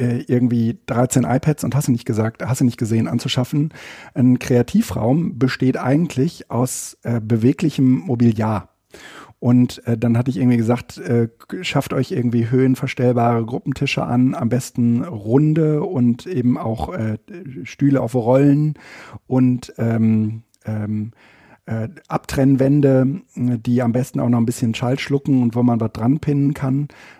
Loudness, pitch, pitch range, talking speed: -19 LUFS, 125 Hz, 115-135 Hz, 145 wpm